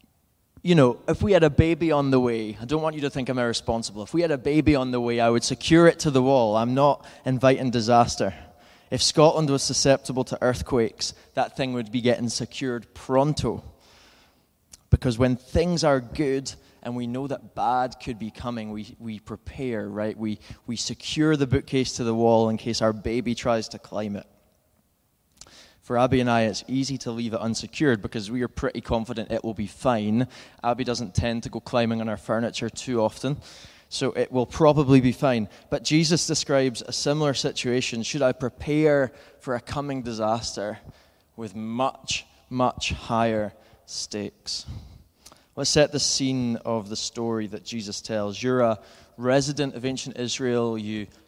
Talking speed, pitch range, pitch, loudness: 180 wpm, 110-135 Hz, 120 Hz, -24 LUFS